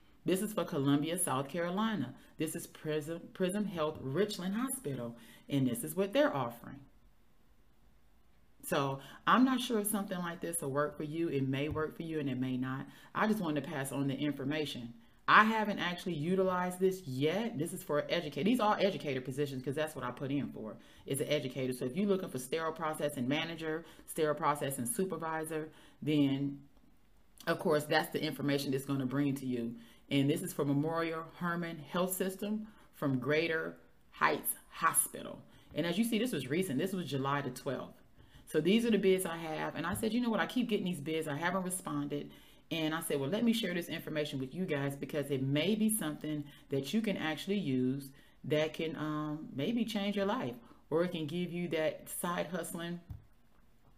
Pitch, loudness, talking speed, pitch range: 155 Hz, -35 LUFS, 195 wpm, 140-185 Hz